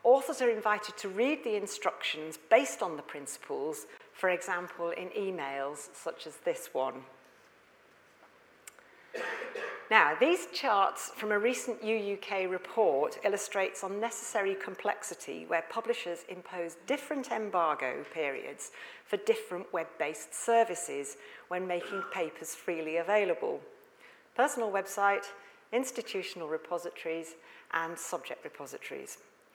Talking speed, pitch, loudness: 105 wpm, 210 Hz, -33 LUFS